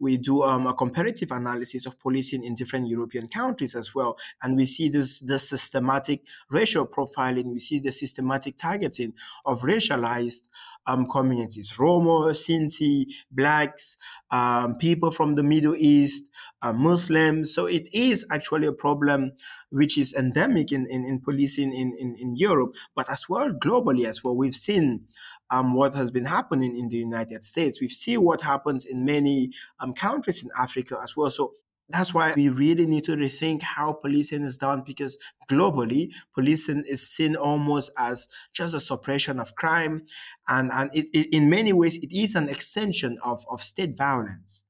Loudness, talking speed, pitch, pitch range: -24 LUFS, 170 wpm, 140 Hz, 130-155 Hz